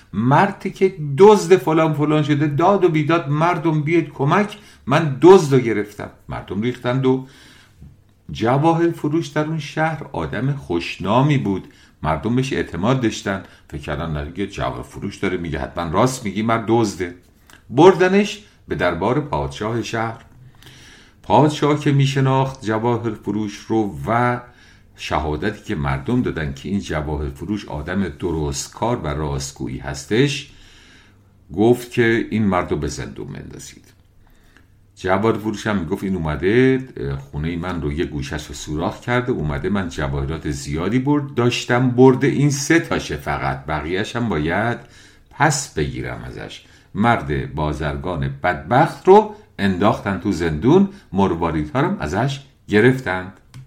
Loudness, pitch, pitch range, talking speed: -19 LUFS, 110 Hz, 85-140 Hz, 135 wpm